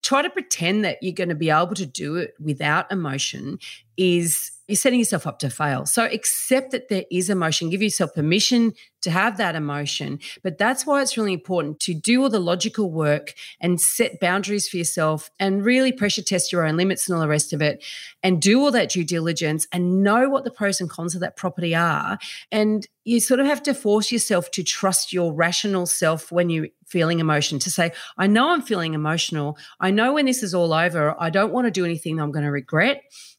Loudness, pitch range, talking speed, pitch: -21 LUFS, 165-215 Hz, 220 wpm, 185 Hz